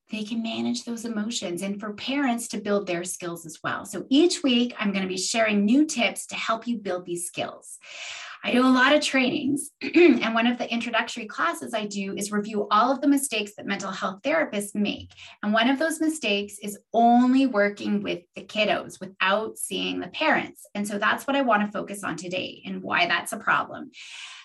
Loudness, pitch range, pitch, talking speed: -24 LUFS, 195-255 Hz, 215 Hz, 210 wpm